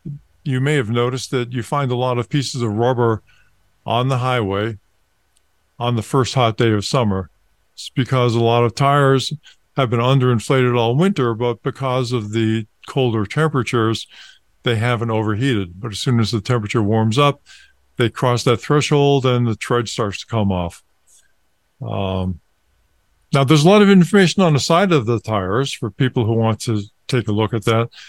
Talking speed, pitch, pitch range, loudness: 180 wpm, 120 Hz, 110-135 Hz, -18 LUFS